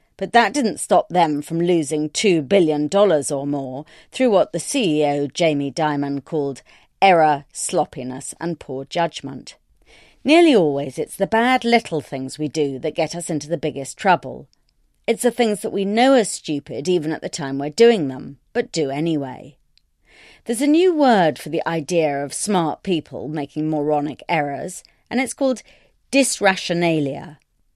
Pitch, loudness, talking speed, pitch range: 160 Hz, -20 LUFS, 160 wpm, 145-195 Hz